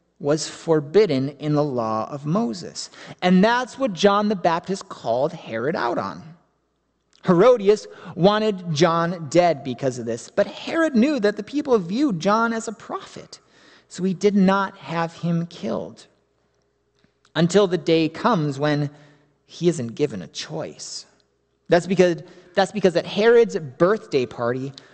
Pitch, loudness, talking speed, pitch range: 175 Hz, -21 LUFS, 145 wpm, 150-205 Hz